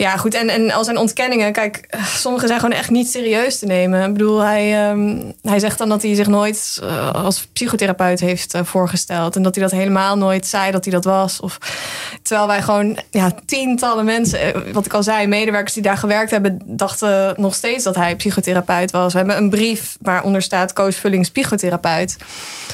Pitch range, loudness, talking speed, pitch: 190-215 Hz, -17 LUFS, 200 wpm, 205 Hz